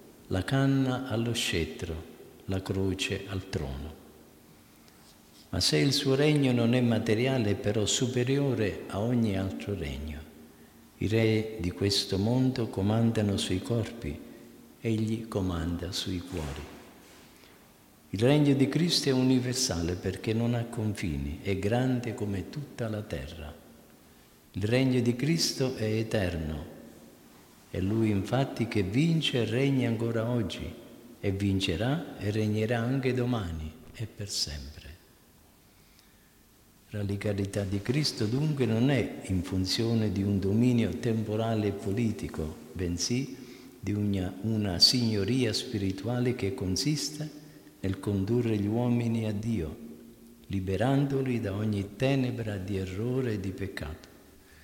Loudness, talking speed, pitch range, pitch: -29 LUFS, 125 wpm, 95-120 Hz, 110 Hz